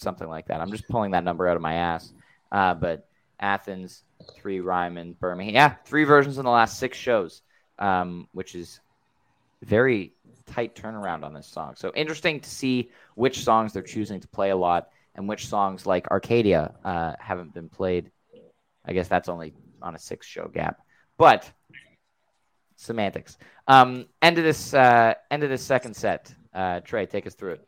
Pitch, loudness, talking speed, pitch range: 100 Hz, -24 LUFS, 180 wpm, 90-125 Hz